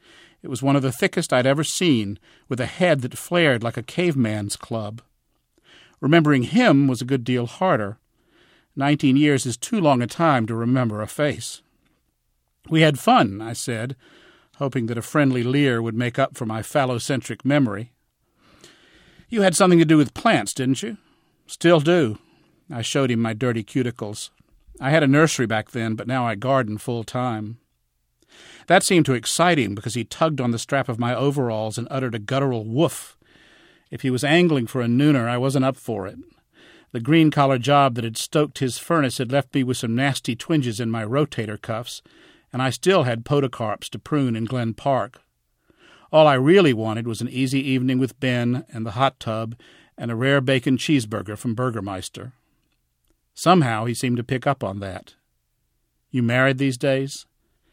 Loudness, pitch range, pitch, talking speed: -21 LUFS, 115-145 Hz, 130 Hz, 185 wpm